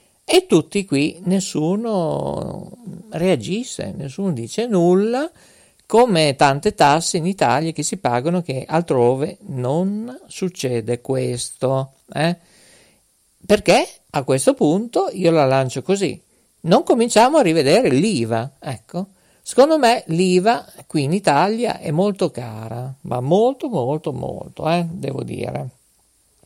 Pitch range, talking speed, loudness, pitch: 135-195 Hz, 120 wpm, -19 LUFS, 170 Hz